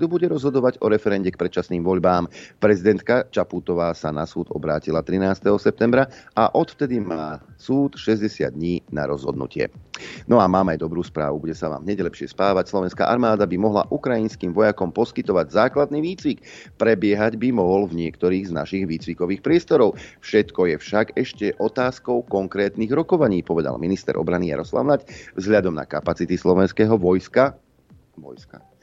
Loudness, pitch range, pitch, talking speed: -21 LUFS, 85-115 Hz, 95 Hz, 145 wpm